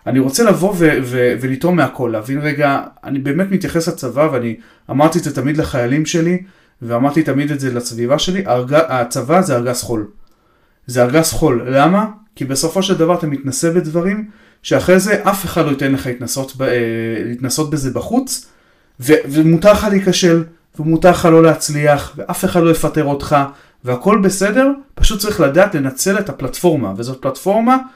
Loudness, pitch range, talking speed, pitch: -15 LUFS, 130-180 Hz, 165 wpm, 155 Hz